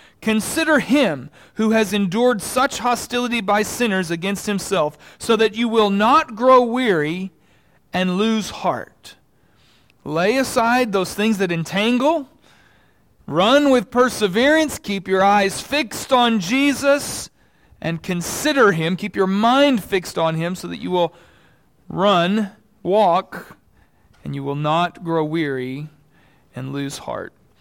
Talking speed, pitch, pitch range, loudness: 130 wpm, 205 Hz, 170-245 Hz, -19 LUFS